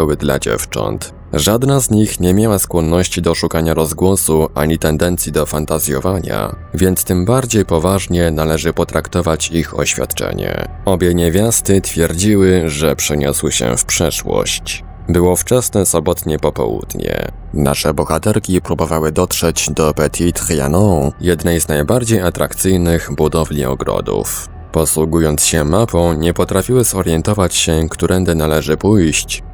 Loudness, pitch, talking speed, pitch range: -14 LUFS, 85 Hz, 120 wpm, 80-95 Hz